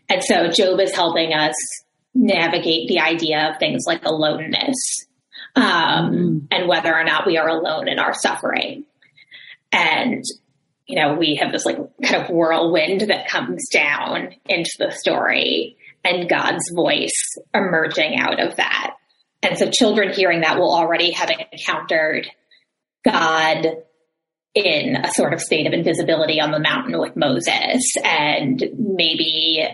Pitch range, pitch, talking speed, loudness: 160-195 Hz, 170 Hz, 145 wpm, -18 LUFS